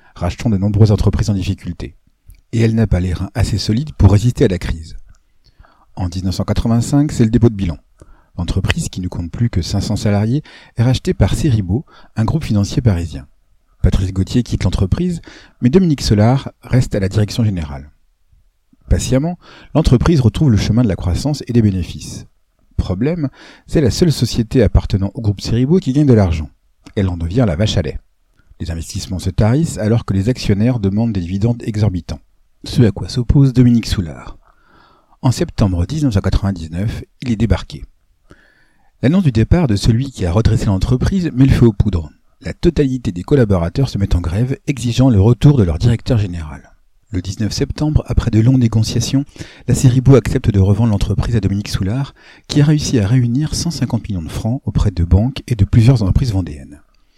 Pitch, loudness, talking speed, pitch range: 110 Hz, -16 LUFS, 180 wpm, 95-125 Hz